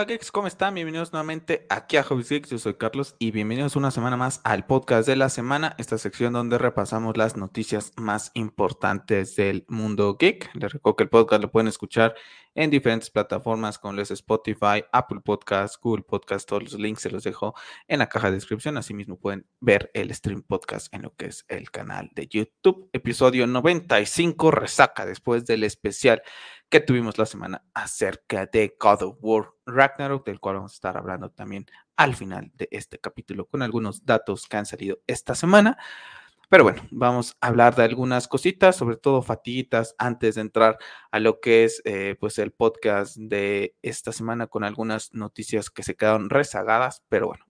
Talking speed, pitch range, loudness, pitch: 185 wpm, 105-130 Hz, -23 LUFS, 115 Hz